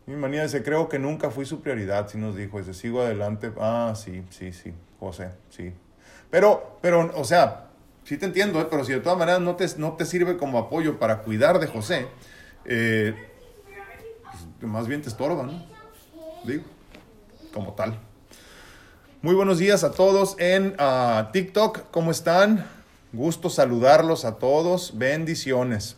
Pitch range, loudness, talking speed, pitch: 110-175 Hz, -23 LUFS, 160 wpm, 145 Hz